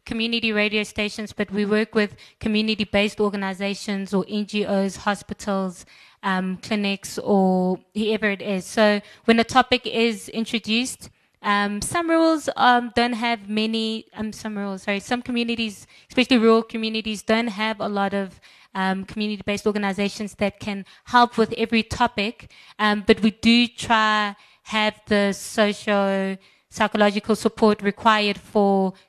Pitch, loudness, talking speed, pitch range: 215 Hz, -22 LUFS, 135 wpm, 200-225 Hz